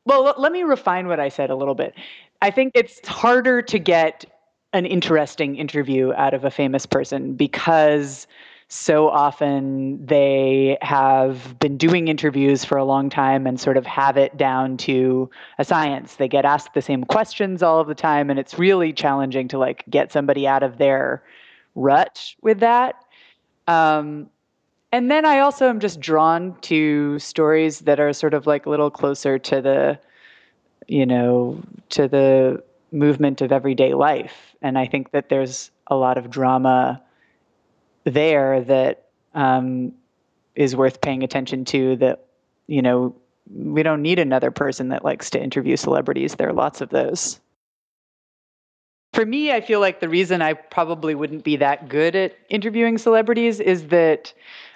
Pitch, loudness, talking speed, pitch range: 145 Hz, -19 LUFS, 165 wpm, 135-175 Hz